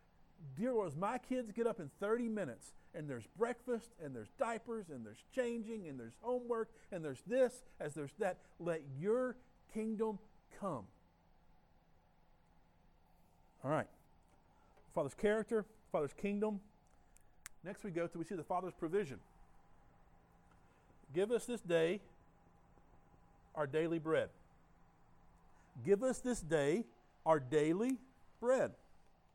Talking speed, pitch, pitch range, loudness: 125 wpm, 190 Hz, 145-225 Hz, -40 LUFS